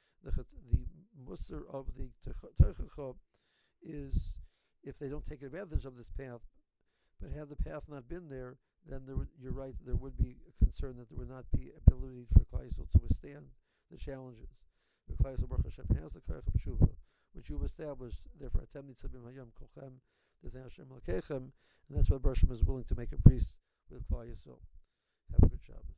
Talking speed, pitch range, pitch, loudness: 160 wpm, 90-135 Hz, 130 Hz, -35 LUFS